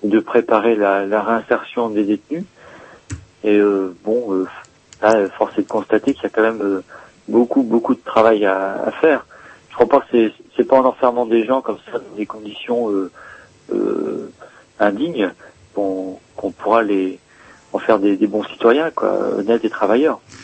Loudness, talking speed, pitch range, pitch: -18 LUFS, 180 wpm, 100-120 Hz, 110 Hz